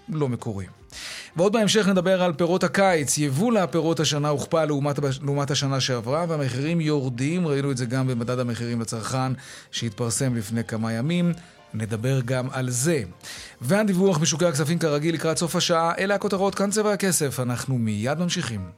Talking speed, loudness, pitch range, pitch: 155 wpm, -23 LUFS, 125-175 Hz, 145 Hz